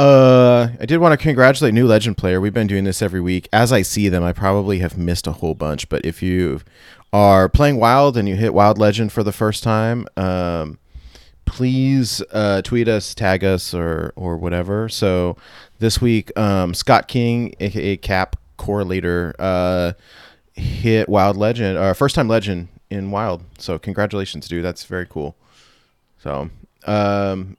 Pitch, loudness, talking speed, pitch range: 100 Hz, -17 LUFS, 175 wpm, 90-115 Hz